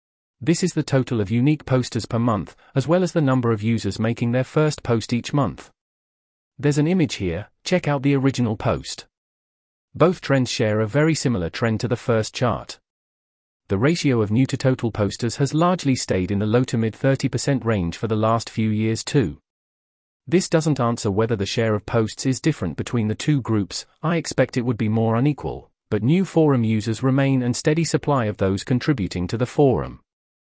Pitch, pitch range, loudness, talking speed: 120 Hz, 110-140 Hz, -21 LUFS, 195 wpm